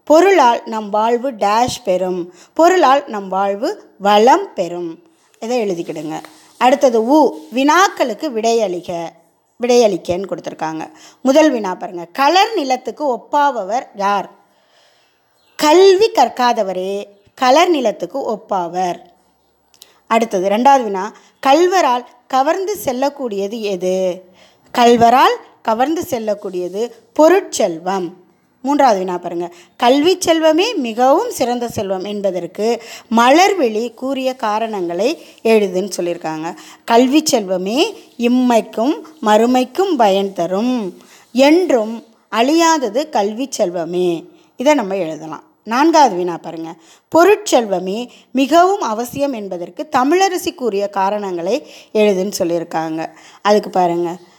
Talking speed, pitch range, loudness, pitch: 90 wpm, 190-285 Hz, -15 LUFS, 230 Hz